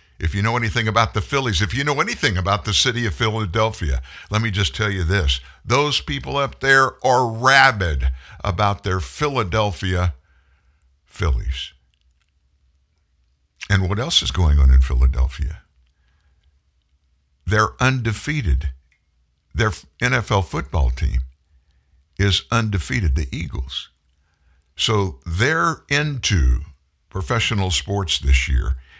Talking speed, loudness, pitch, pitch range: 120 wpm, -20 LUFS, 80 Hz, 70-110 Hz